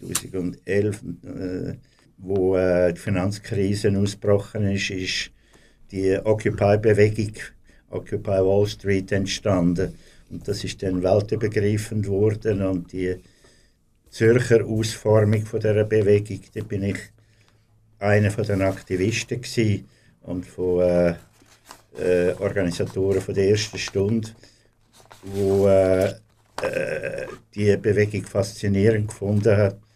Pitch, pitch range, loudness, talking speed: 100 Hz, 95-110 Hz, -22 LUFS, 100 wpm